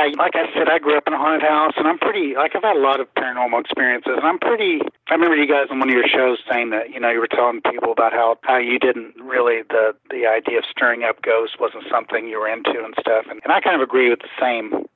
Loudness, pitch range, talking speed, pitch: -18 LUFS, 125-165 Hz, 280 wpm, 135 Hz